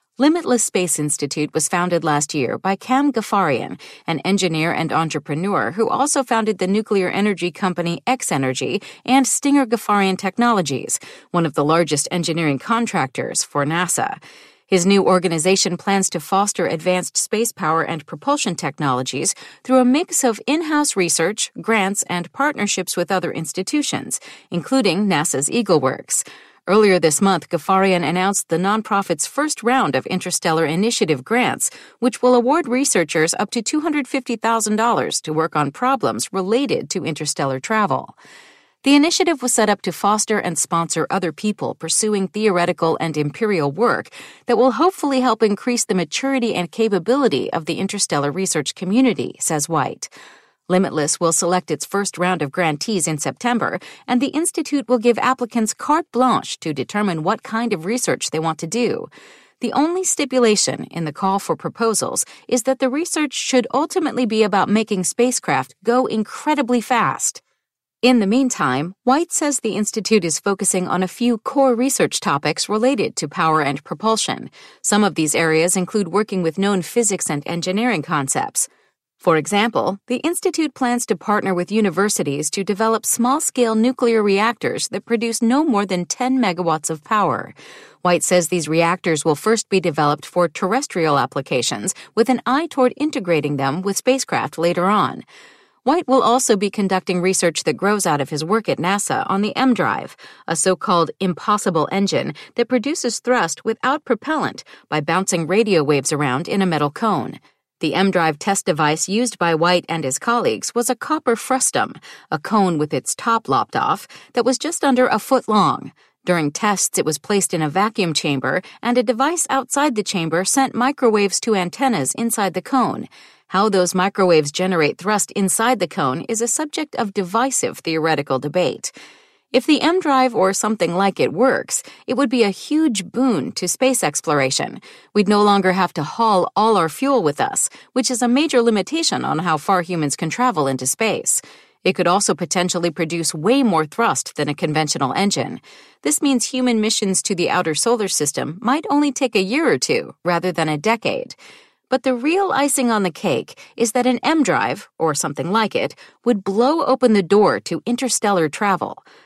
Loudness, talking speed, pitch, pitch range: -19 LUFS, 170 wpm, 205 Hz, 170-250 Hz